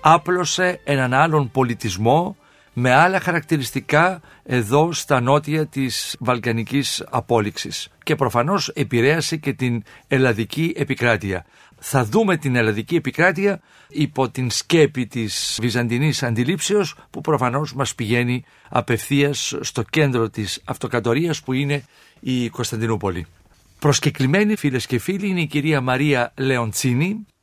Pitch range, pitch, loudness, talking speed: 120-155 Hz, 135 Hz, -20 LUFS, 115 wpm